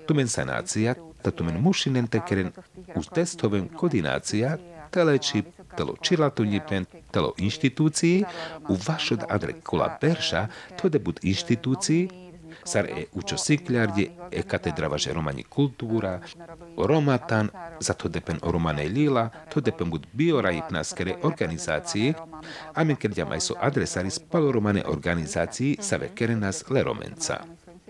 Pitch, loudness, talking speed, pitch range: 130 Hz, -26 LUFS, 125 wpm, 100-160 Hz